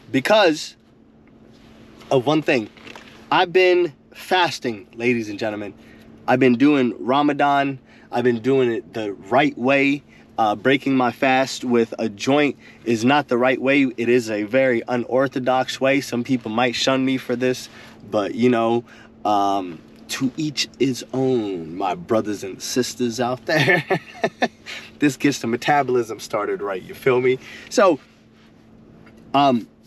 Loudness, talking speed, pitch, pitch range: -20 LUFS, 145 wpm, 125 Hz, 115-135 Hz